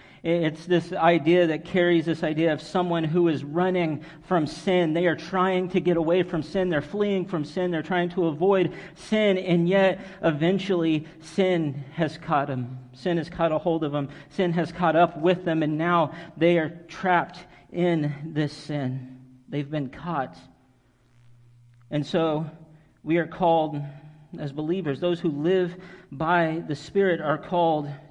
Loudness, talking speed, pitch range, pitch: -25 LUFS, 165 wpm, 150-175 Hz, 165 Hz